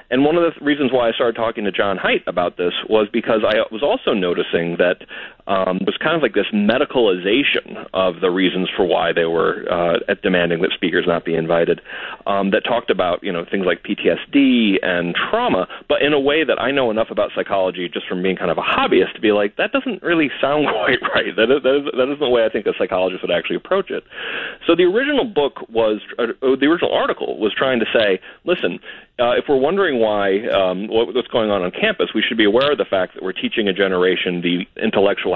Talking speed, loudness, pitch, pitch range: 230 wpm, -18 LUFS, 100 Hz, 90-140 Hz